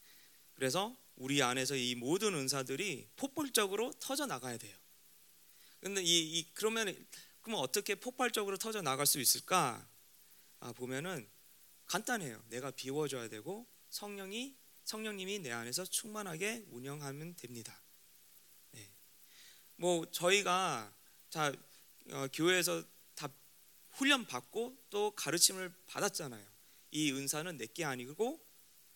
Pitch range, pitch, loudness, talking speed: 130-210 Hz, 170 Hz, -36 LUFS, 255 characters per minute